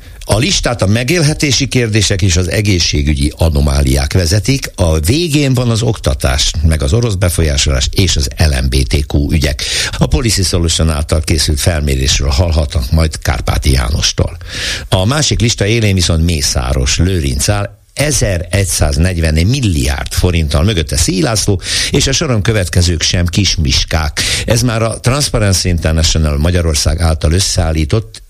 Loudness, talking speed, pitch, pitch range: -12 LUFS, 125 wpm, 90 Hz, 80-105 Hz